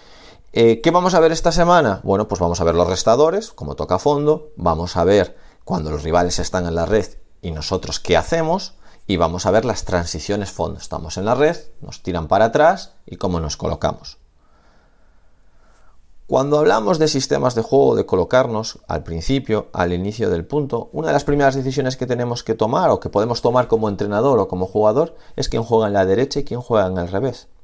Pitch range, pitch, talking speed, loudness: 90-140 Hz, 110 Hz, 205 wpm, -18 LUFS